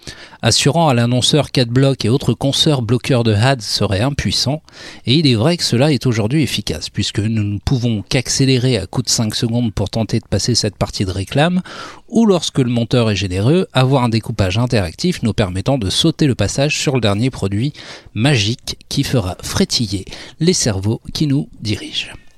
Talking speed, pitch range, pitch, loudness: 185 wpm, 105-140 Hz, 120 Hz, -16 LUFS